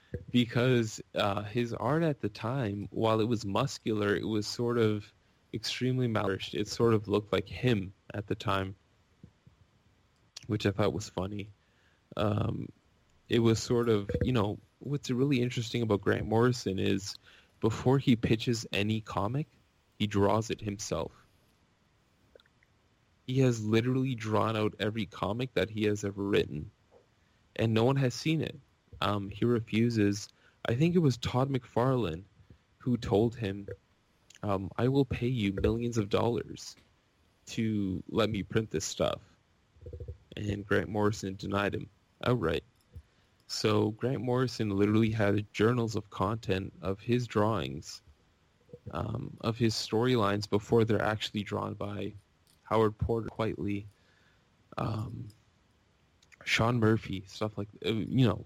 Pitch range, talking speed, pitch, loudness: 100-120 Hz, 140 wpm, 105 Hz, -31 LUFS